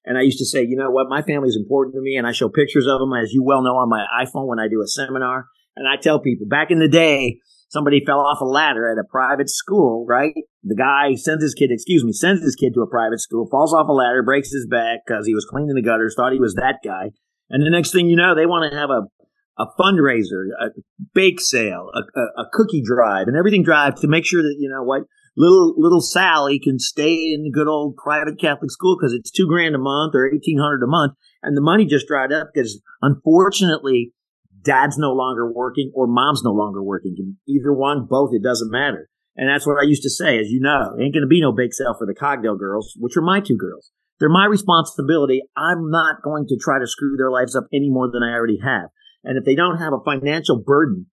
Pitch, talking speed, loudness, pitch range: 140 Hz, 245 wpm, -18 LUFS, 125-155 Hz